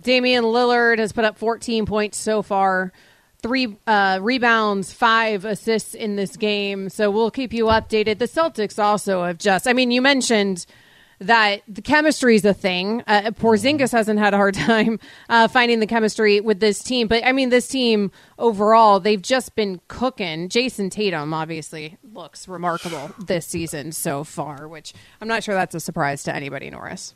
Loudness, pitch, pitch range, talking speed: -19 LUFS, 215 Hz, 190-230 Hz, 175 wpm